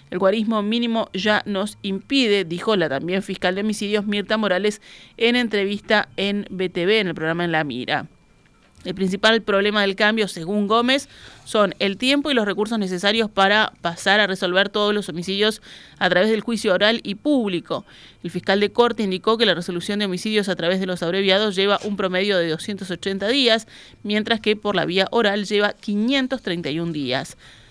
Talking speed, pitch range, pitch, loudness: 180 wpm, 185-215 Hz, 205 Hz, -20 LUFS